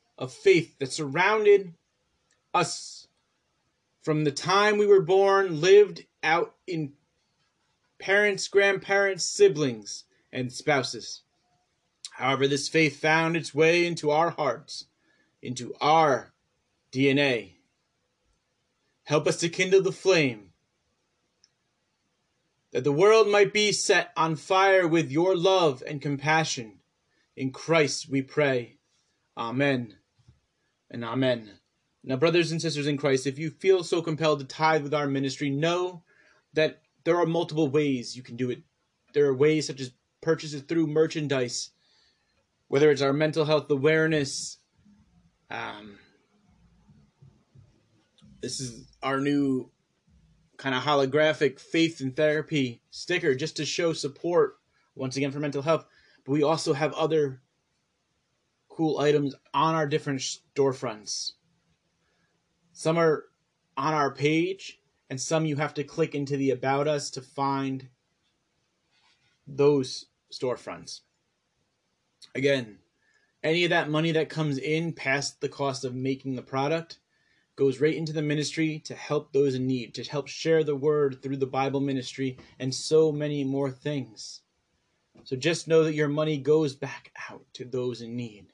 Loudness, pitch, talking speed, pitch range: -26 LUFS, 150 Hz, 135 wpm, 135-160 Hz